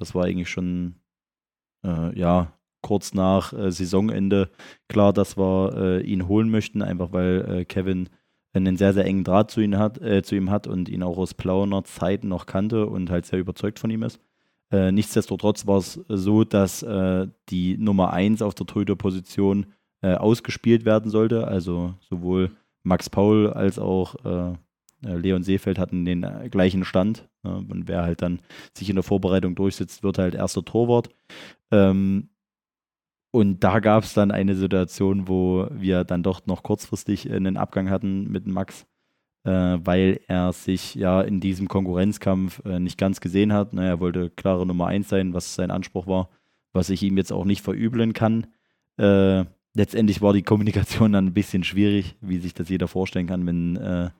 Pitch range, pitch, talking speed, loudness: 90-105 Hz, 95 Hz, 170 wpm, -23 LUFS